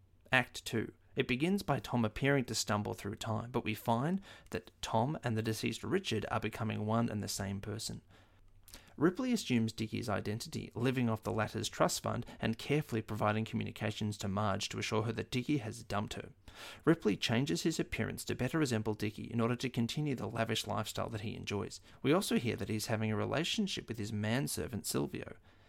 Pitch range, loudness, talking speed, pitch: 105-120 Hz, -36 LUFS, 190 wpm, 110 Hz